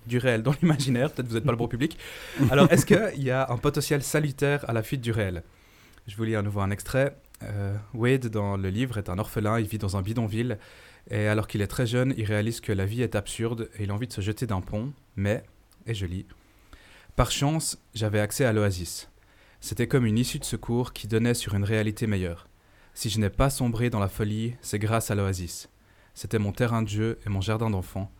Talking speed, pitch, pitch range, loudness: 235 wpm, 110 Hz, 100-125 Hz, -27 LUFS